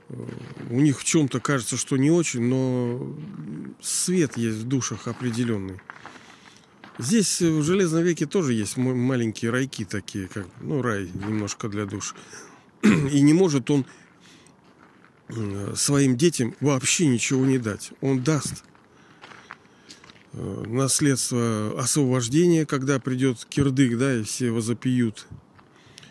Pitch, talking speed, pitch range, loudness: 130 Hz, 115 wpm, 115-145 Hz, -23 LUFS